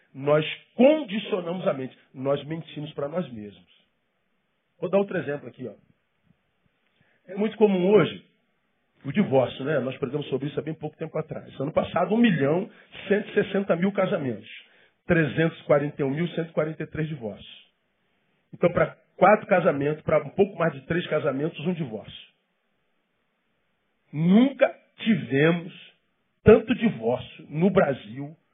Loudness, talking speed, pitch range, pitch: -24 LUFS, 135 wpm, 145-195 Hz, 165 Hz